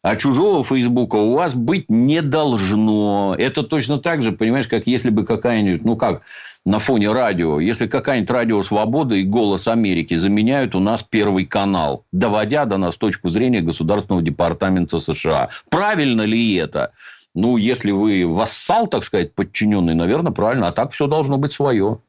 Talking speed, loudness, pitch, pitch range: 165 wpm, -18 LUFS, 110 Hz, 100-135 Hz